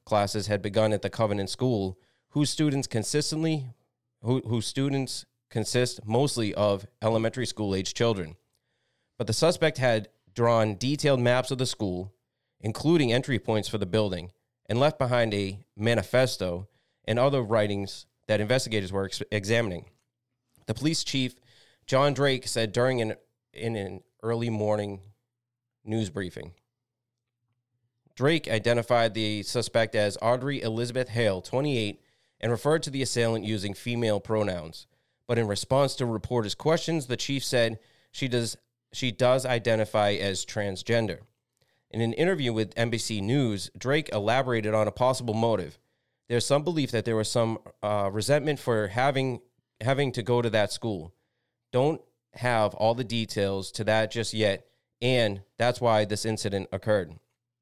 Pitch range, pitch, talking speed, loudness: 105-125 Hz, 115 Hz, 145 wpm, -27 LUFS